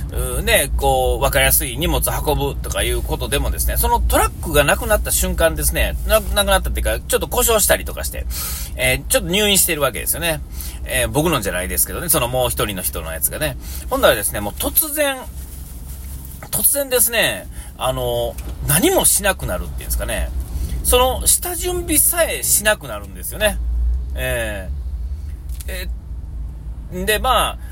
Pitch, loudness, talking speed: 75 Hz, -17 LUFS, 365 characters per minute